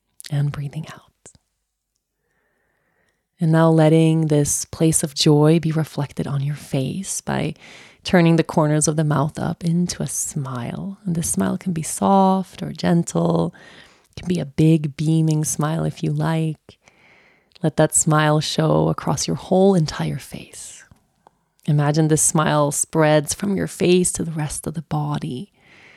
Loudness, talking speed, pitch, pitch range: -19 LUFS, 155 wpm, 160 Hz, 150-175 Hz